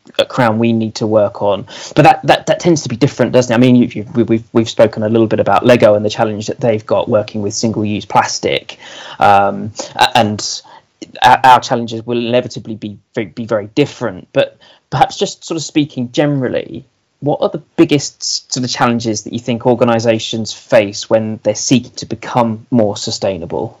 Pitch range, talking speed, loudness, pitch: 110-125 Hz, 190 wpm, -14 LUFS, 115 Hz